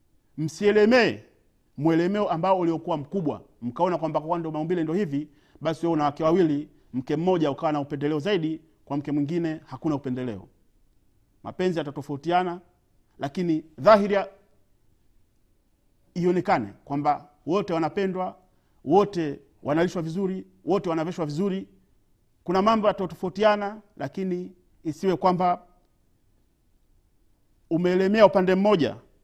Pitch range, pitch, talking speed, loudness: 145-185 Hz, 165 Hz, 105 wpm, -25 LUFS